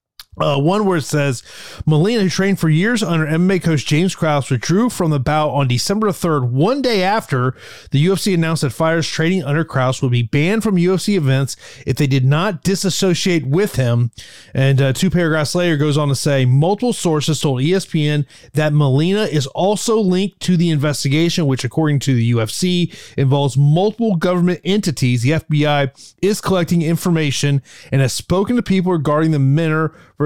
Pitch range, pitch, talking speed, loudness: 140-185 Hz, 160 Hz, 175 wpm, -16 LUFS